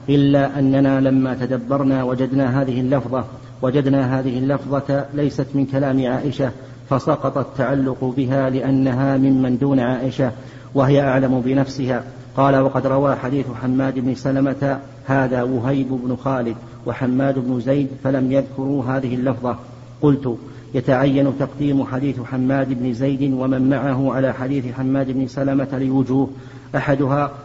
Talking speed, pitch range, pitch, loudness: 125 wpm, 130-135 Hz, 135 Hz, -19 LUFS